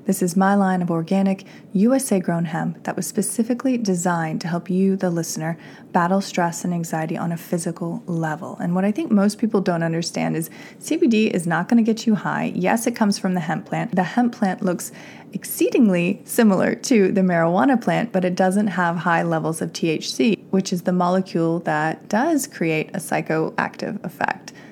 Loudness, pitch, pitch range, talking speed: -21 LUFS, 185 Hz, 170-210 Hz, 190 wpm